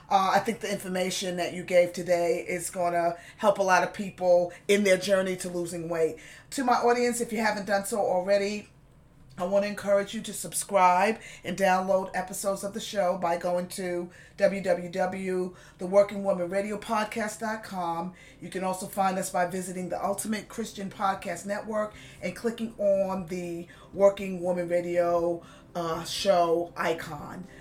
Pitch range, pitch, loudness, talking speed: 175-200 Hz, 185 Hz, -28 LUFS, 155 wpm